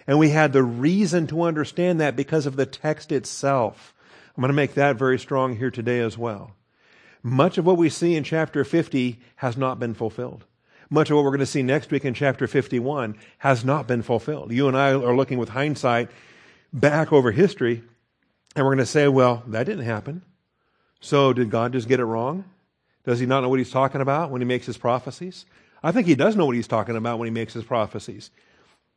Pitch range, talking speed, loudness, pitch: 120-150 Hz, 220 wpm, -22 LUFS, 135 Hz